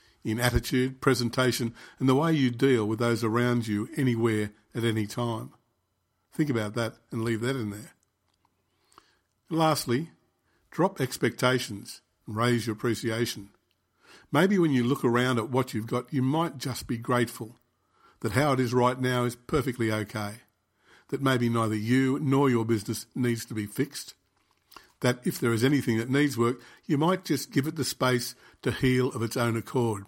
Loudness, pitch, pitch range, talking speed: -27 LUFS, 120 Hz, 115-130 Hz, 175 wpm